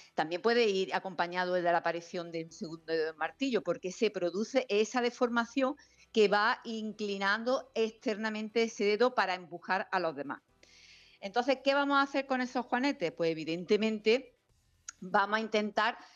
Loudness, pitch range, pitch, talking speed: -32 LUFS, 175-235 Hz, 210 Hz, 160 wpm